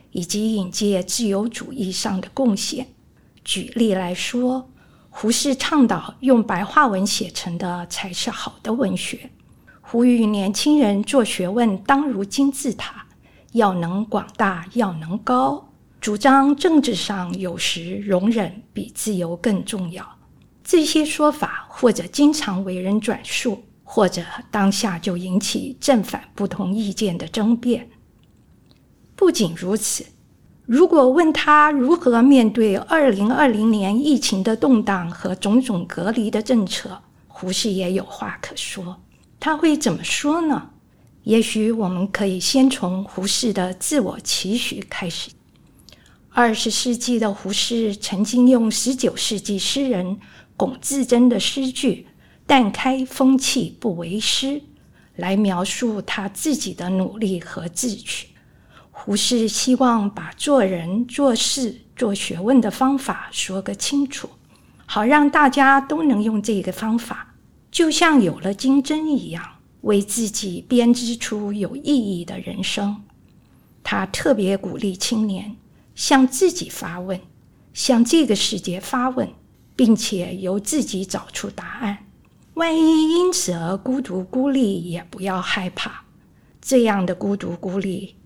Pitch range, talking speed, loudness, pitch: 195-260 Hz, 200 characters per minute, -20 LUFS, 220 Hz